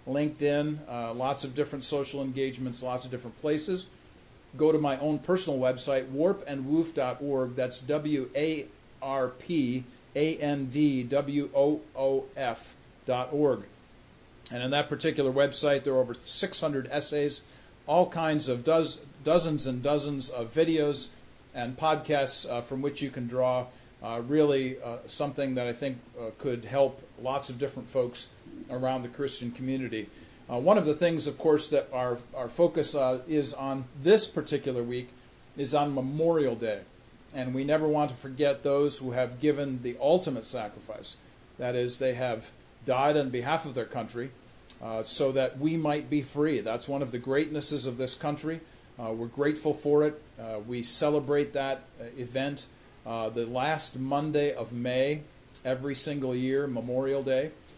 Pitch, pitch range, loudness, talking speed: 140 Hz, 125-150 Hz, -29 LUFS, 160 wpm